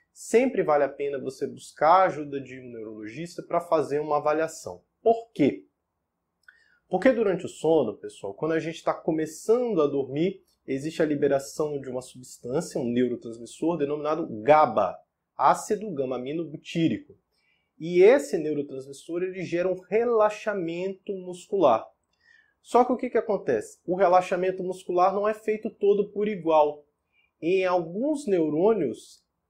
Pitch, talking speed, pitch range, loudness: 170 Hz, 135 wpm, 145-200 Hz, -25 LUFS